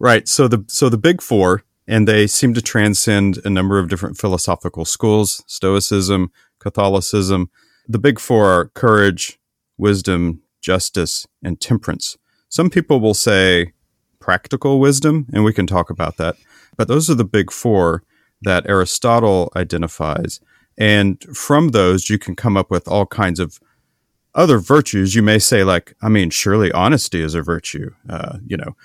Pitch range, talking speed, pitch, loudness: 90-110 Hz, 160 wpm, 100 Hz, -16 LUFS